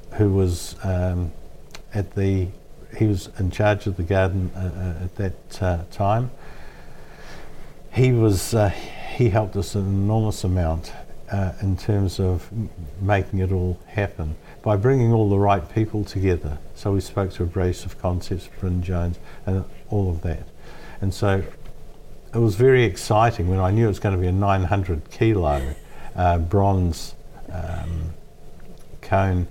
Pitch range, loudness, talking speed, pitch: 90-105 Hz, -23 LUFS, 155 wpm, 95 Hz